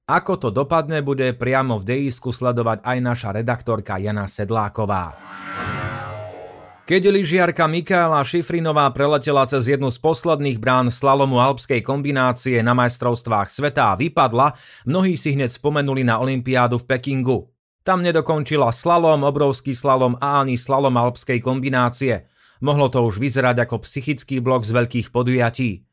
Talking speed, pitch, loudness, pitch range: 135 wpm, 130 Hz, -19 LUFS, 120-145 Hz